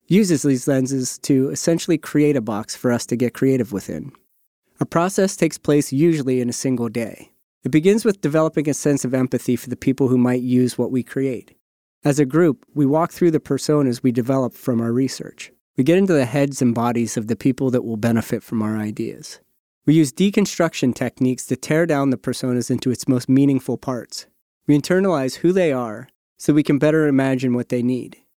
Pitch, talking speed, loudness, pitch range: 135 Hz, 205 wpm, -19 LUFS, 125-150 Hz